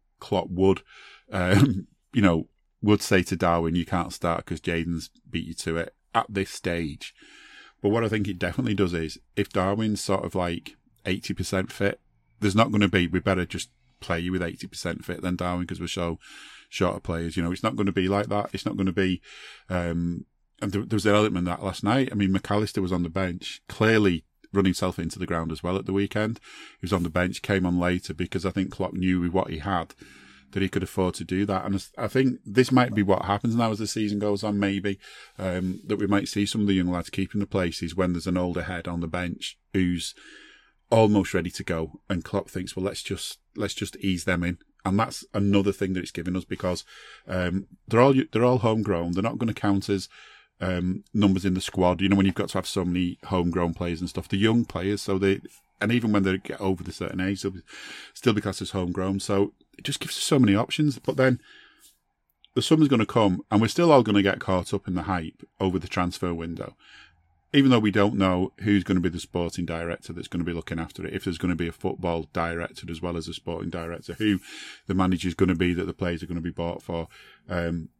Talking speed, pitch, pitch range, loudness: 240 wpm, 95 Hz, 90-100 Hz, -26 LUFS